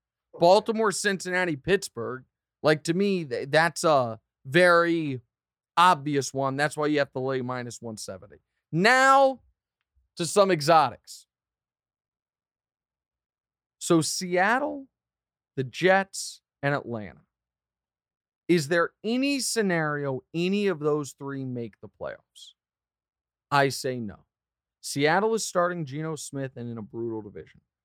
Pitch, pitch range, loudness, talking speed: 150 Hz, 120-180 Hz, -25 LUFS, 115 wpm